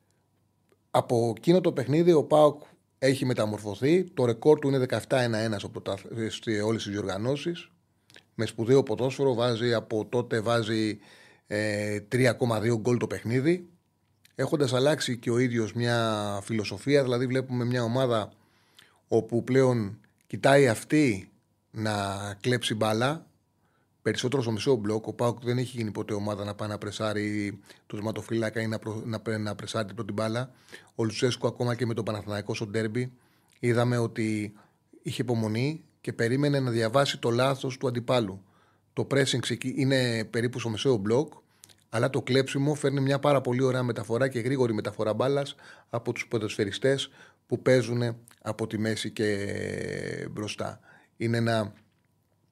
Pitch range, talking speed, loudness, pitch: 110-130 Hz, 145 wpm, -28 LUFS, 115 Hz